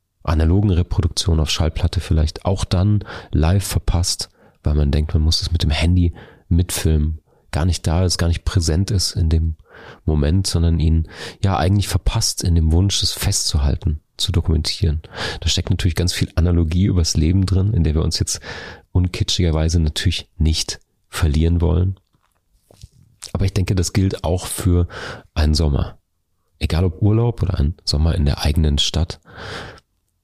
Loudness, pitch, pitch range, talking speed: -19 LUFS, 90 Hz, 80-95 Hz, 160 wpm